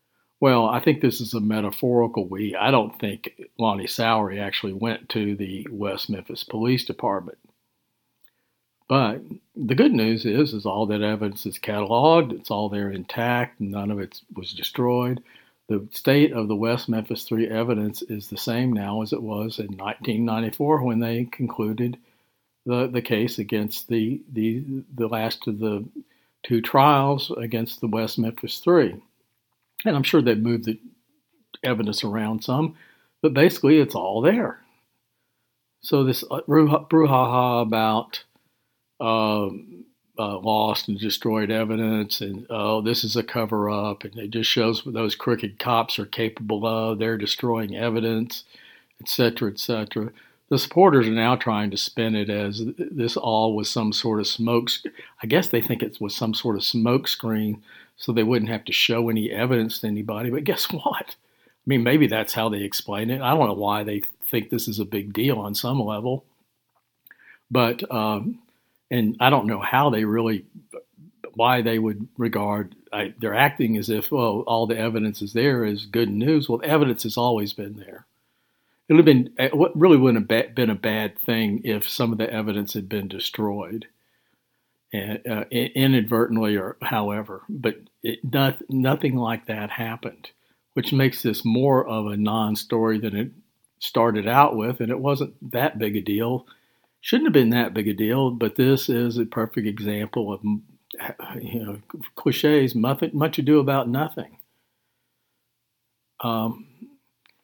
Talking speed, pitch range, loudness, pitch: 165 wpm, 110-125 Hz, -23 LUFS, 115 Hz